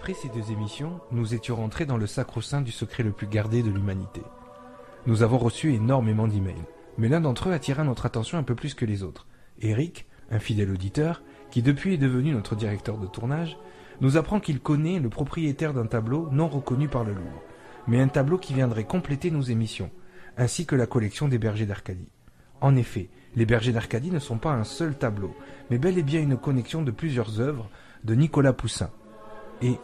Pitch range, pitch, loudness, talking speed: 110-145 Hz, 120 Hz, -26 LUFS, 200 wpm